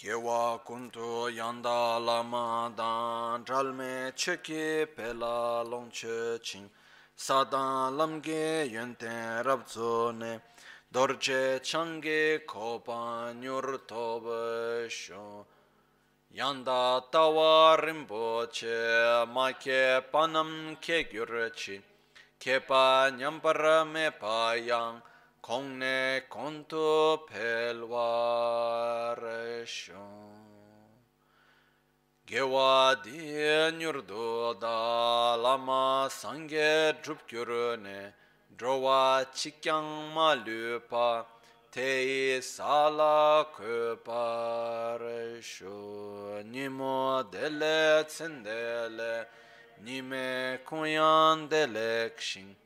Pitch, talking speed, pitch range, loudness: 120 Hz, 70 wpm, 115-150 Hz, -30 LUFS